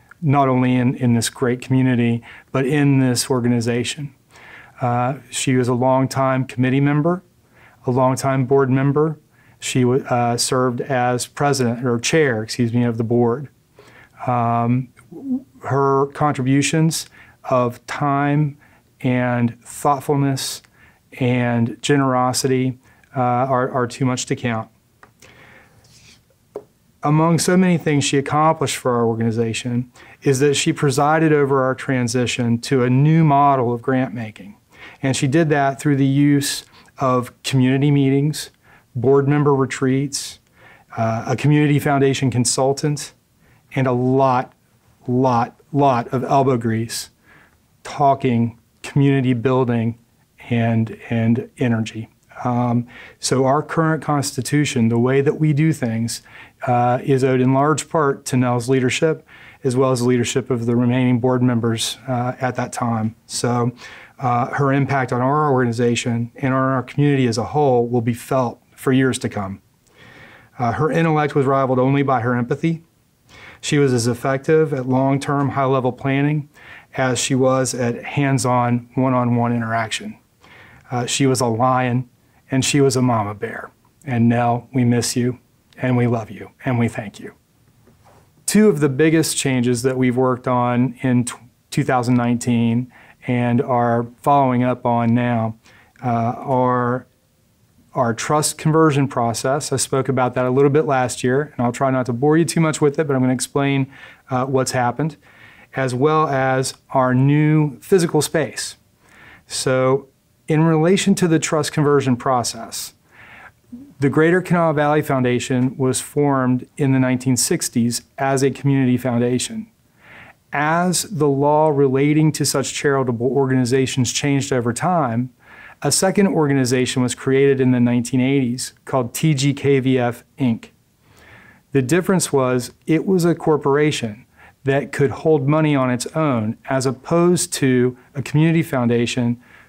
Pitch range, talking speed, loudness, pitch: 120-140 Hz, 145 wpm, -18 LUFS, 130 Hz